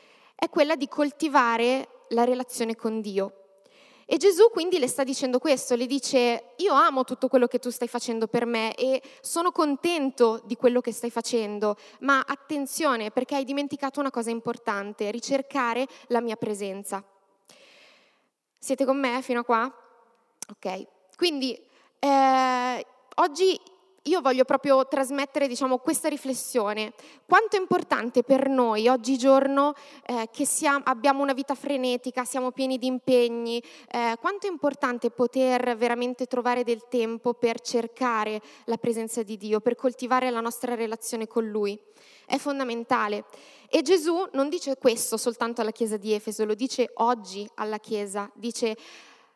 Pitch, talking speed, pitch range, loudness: 250 Hz, 145 wpm, 230-275 Hz, -26 LUFS